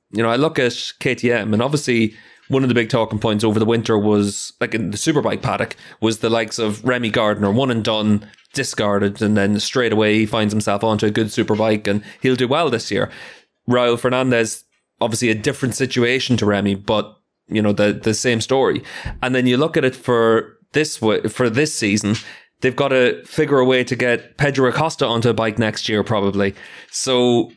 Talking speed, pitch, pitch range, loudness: 205 wpm, 115 Hz, 110-125 Hz, -18 LUFS